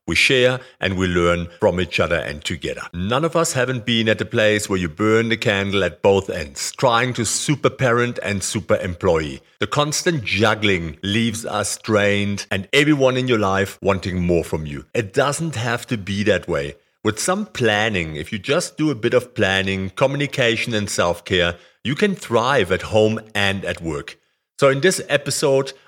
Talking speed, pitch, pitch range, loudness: 190 wpm, 110 Hz, 95-130 Hz, -19 LUFS